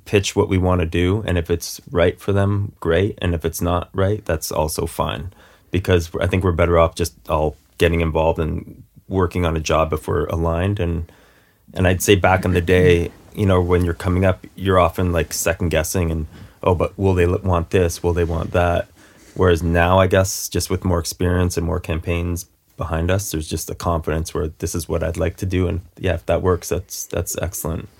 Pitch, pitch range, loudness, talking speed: 85 Hz, 85-95 Hz, -20 LUFS, 220 wpm